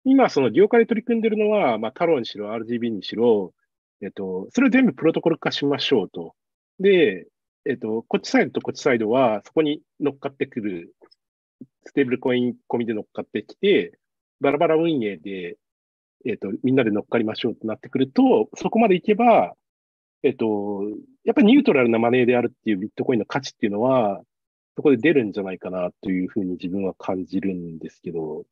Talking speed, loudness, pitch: 415 characters per minute, -22 LUFS, 120 Hz